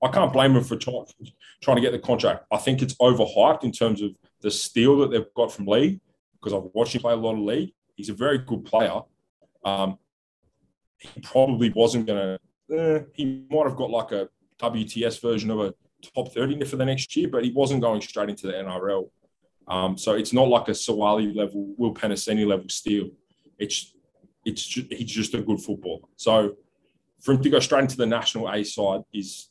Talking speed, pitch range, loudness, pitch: 205 wpm, 105-130 Hz, -24 LUFS, 115 Hz